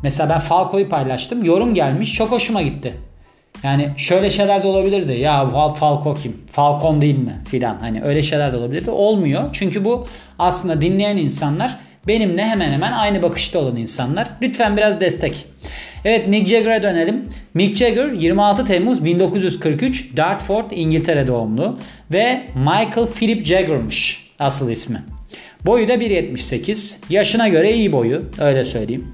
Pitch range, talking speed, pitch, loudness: 145-205 Hz, 140 wpm, 175 Hz, -17 LUFS